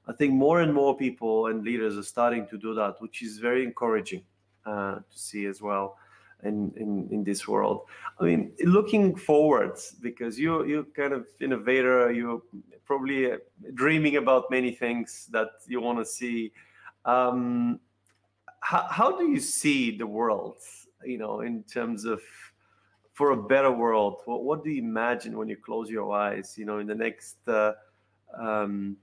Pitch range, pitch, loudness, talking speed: 105-140 Hz, 120 Hz, -27 LUFS, 170 wpm